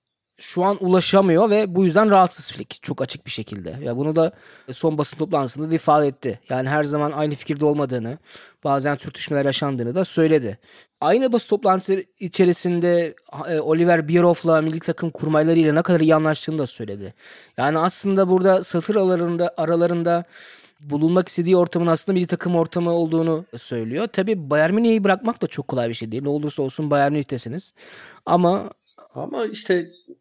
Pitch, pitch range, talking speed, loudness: 165 Hz, 145-185 Hz, 155 wpm, -20 LUFS